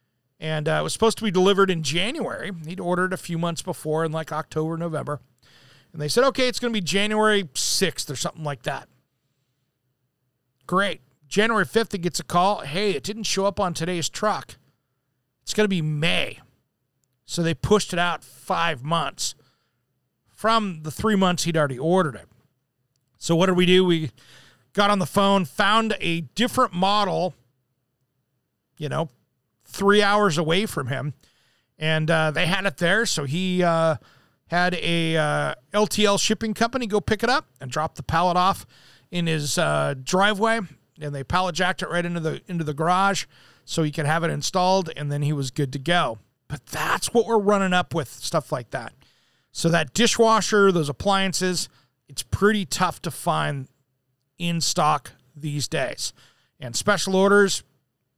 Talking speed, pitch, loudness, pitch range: 175 wpm, 165 Hz, -23 LUFS, 135-190 Hz